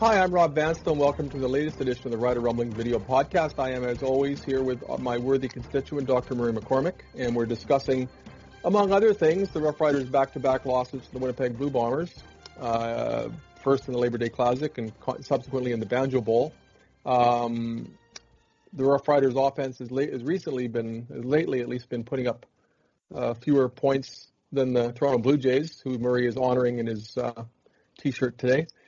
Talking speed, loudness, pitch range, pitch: 195 wpm, -26 LUFS, 120-140 Hz, 130 Hz